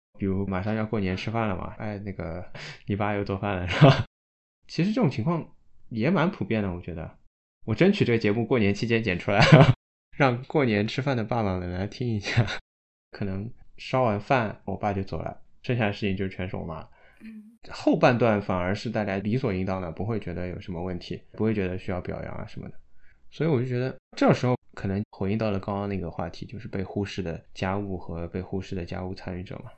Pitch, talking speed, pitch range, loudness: 100 Hz, 320 characters per minute, 95-120 Hz, -26 LUFS